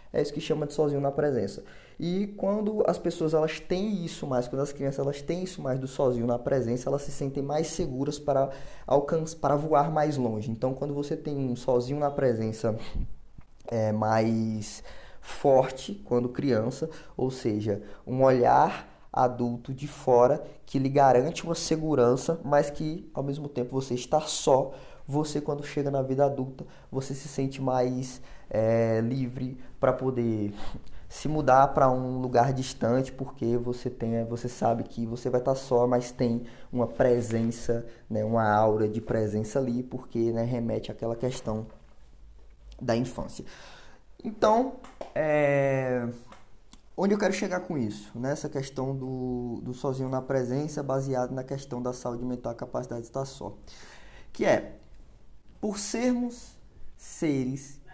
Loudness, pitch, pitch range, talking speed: -28 LUFS, 130 Hz, 120-145 Hz, 155 wpm